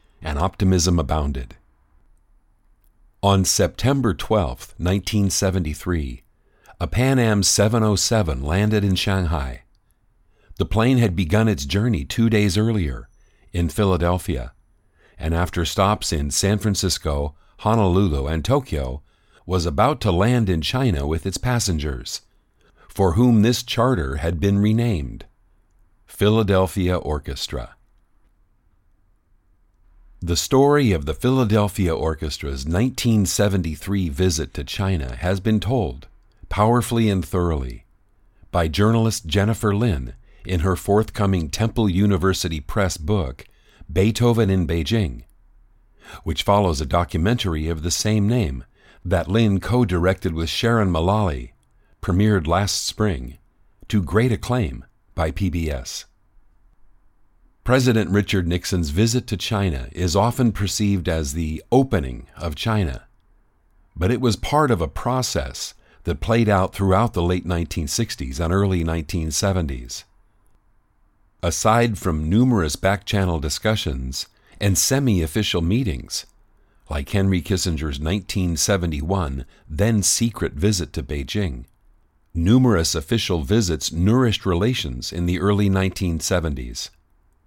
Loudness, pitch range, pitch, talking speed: -21 LUFS, 80-105 Hz, 95 Hz, 110 wpm